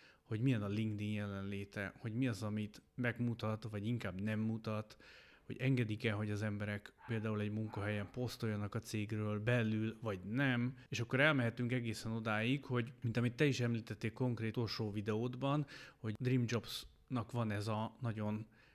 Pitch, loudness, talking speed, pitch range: 115 Hz, -39 LUFS, 155 wpm, 105-120 Hz